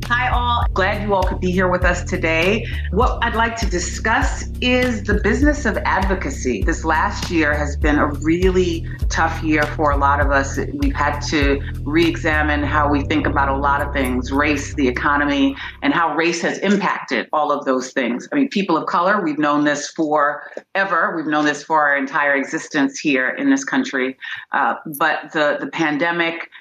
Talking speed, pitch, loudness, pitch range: 190 wpm, 150 Hz, -18 LUFS, 140-170 Hz